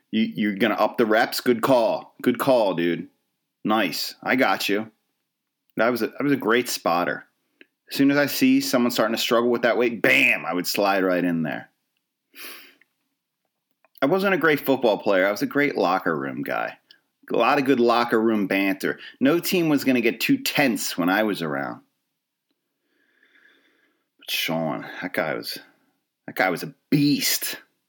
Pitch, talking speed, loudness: 140 Hz, 180 wpm, -22 LUFS